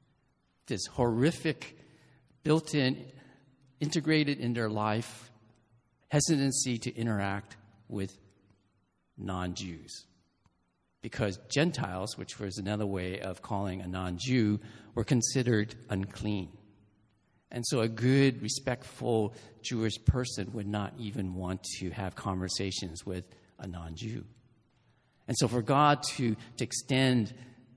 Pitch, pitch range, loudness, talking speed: 110 Hz, 100-125 Hz, -32 LUFS, 115 wpm